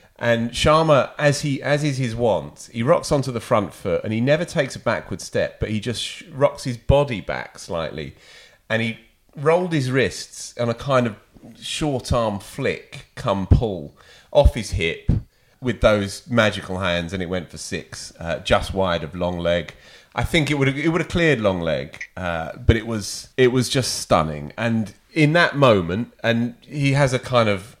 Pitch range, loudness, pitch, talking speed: 100-135 Hz, -21 LUFS, 120 Hz, 195 wpm